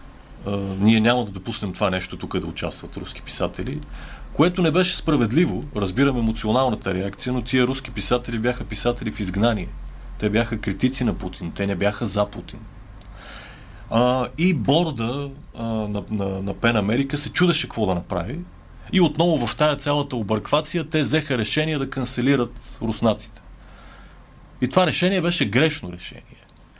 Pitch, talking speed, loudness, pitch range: 115 Hz, 145 wpm, -22 LUFS, 100-140 Hz